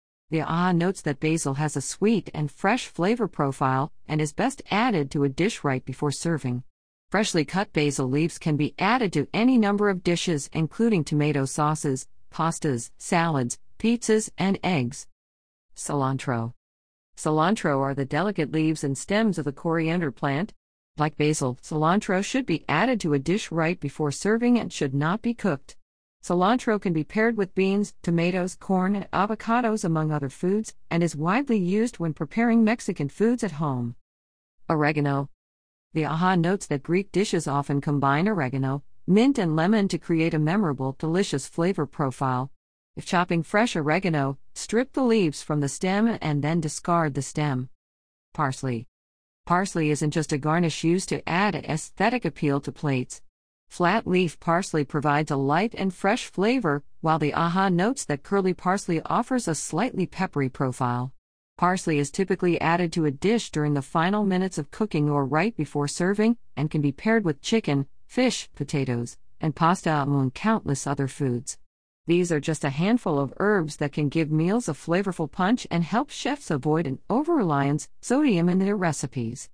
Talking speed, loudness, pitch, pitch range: 165 wpm, -25 LUFS, 160 Hz, 140-195 Hz